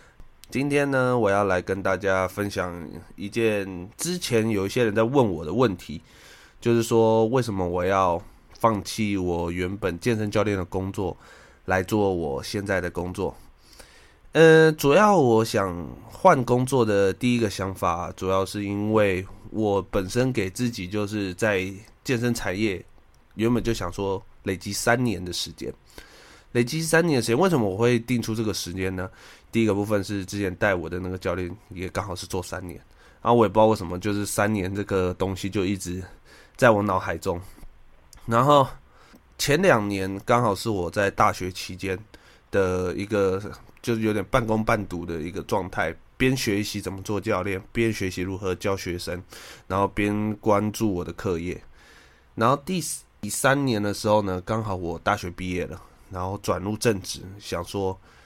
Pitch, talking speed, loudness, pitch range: 100 Hz, 250 characters per minute, -24 LUFS, 95-115 Hz